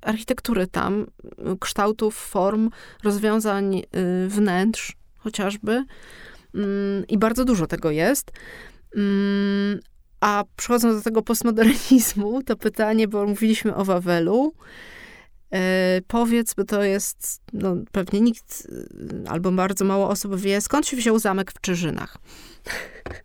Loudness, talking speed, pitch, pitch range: -22 LUFS, 115 wpm, 205 Hz, 195-225 Hz